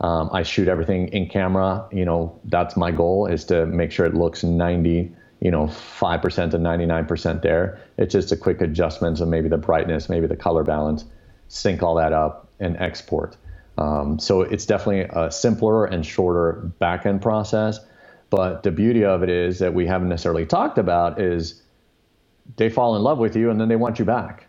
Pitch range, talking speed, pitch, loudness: 85-100 Hz, 195 wpm, 85 Hz, -21 LUFS